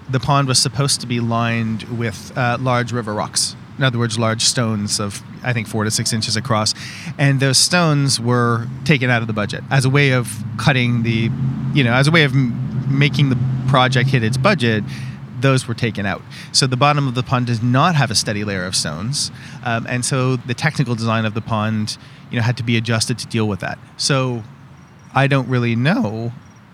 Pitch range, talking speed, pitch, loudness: 115-135 Hz, 210 wpm, 125 Hz, -18 LUFS